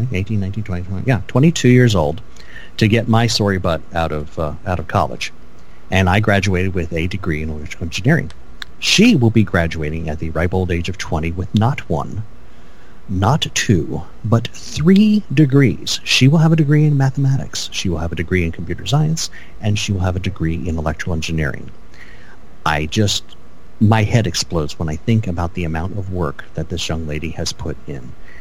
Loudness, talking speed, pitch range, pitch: -17 LUFS, 190 wpm, 80-115 Hz, 95 Hz